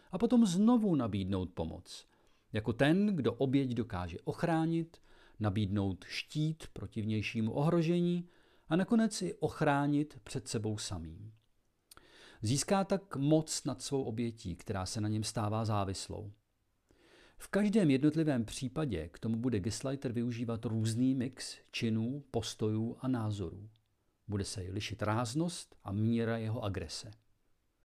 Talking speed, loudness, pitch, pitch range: 125 wpm, -34 LUFS, 115 Hz, 105-145 Hz